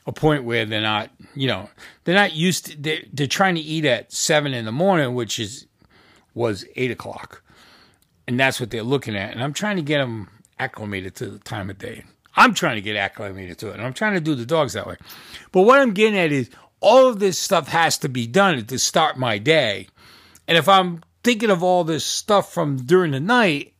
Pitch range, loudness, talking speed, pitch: 115-180 Hz, -20 LUFS, 225 wpm, 145 Hz